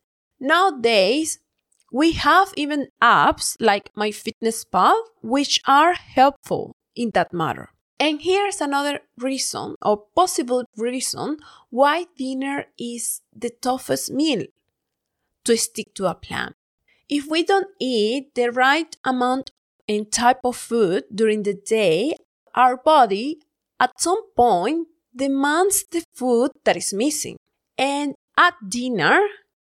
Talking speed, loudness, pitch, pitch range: 120 wpm, -20 LUFS, 265 Hz, 235-315 Hz